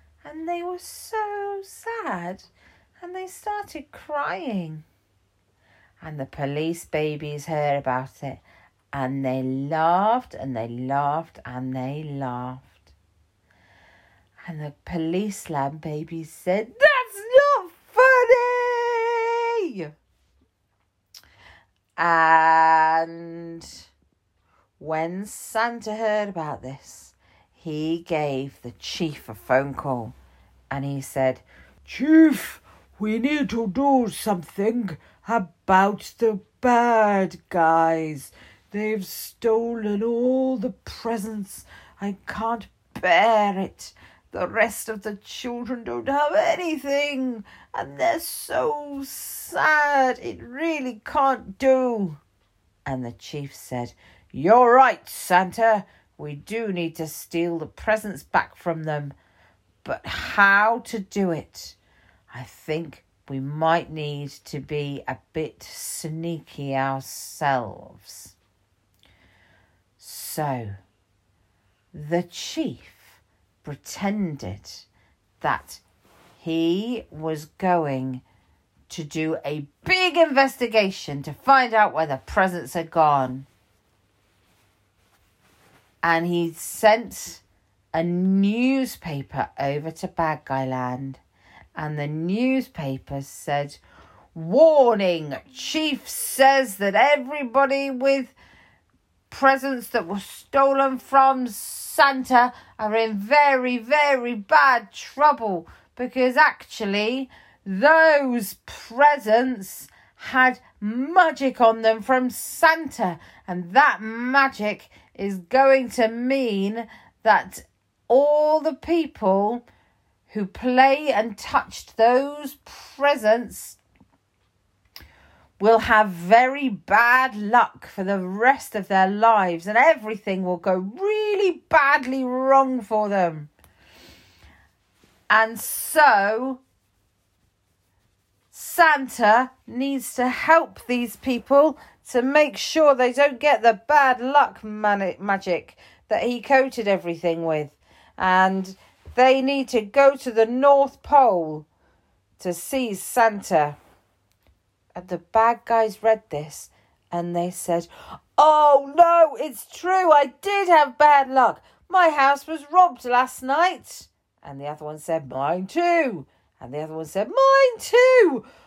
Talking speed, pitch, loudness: 105 wpm, 190 Hz, -21 LUFS